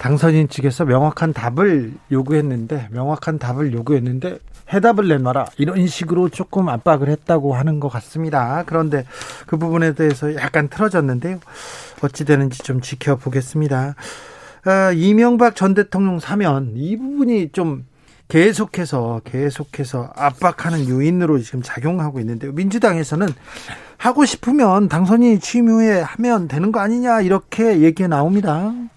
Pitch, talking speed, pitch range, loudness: 160 Hz, 330 characters per minute, 140-190 Hz, -17 LUFS